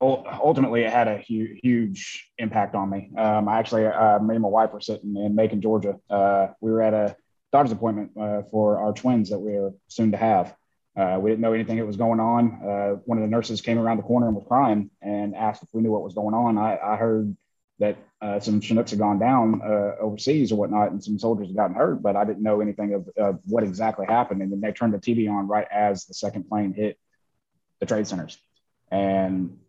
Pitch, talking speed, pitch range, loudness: 105 Hz, 235 wpm, 100-115 Hz, -24 LUFS